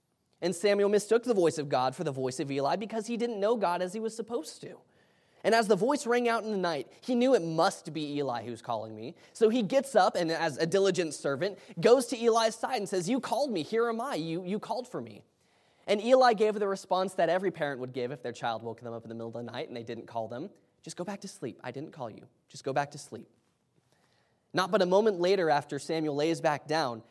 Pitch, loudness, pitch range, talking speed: 175 Hz, -29 LUFS, 140-220 Hz, 260 wpm